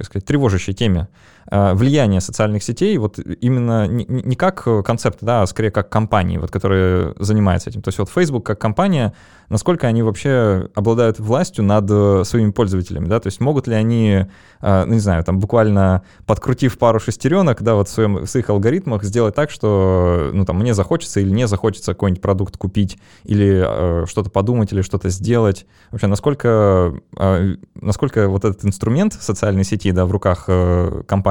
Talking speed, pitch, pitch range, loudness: 175 wpm, 105 Hz, 95-115 Hz, -17 LUFS